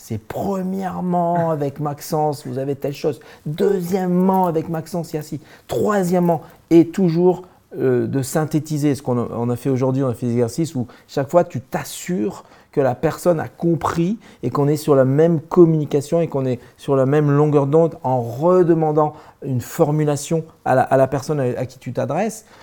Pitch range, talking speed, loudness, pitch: 135-170 Hz, 180 wpm, -19 LUFS, 150 Hz